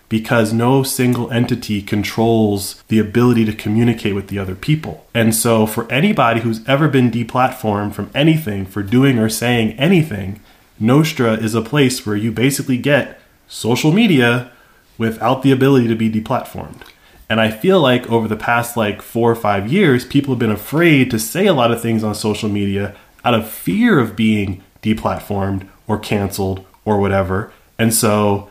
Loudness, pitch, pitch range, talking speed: -16 LUFS, 115 Hz, 105-125 Hz, 170 wpm